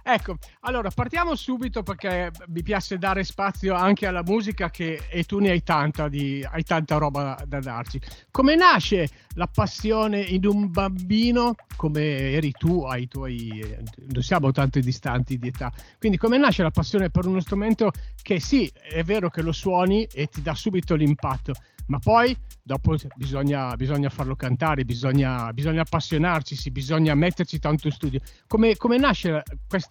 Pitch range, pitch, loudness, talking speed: 140-195 Hz, 160 Hz, -24 LUFS, 165 wpm